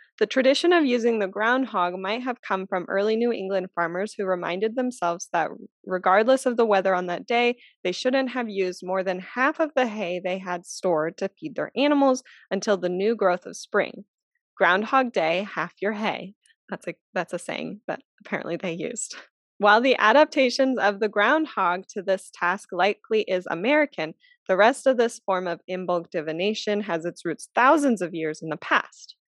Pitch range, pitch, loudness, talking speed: 180-250 Hz, 205 Hz, -24 LUFS, 185 wpm